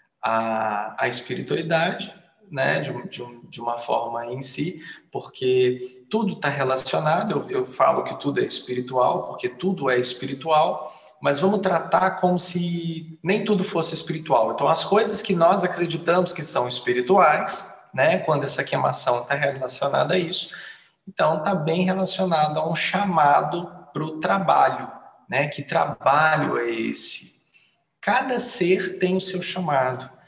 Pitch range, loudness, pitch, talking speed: 130-185 Hz, -23 LUFS, 165 Hz, 145 wpm